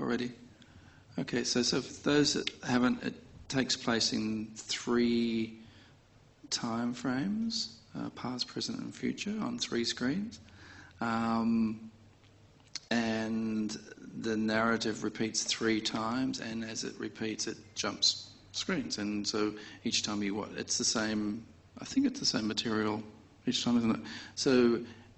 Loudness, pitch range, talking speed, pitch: -32 LUFS, 110-120 Hz, 135 wpm, 115 Hz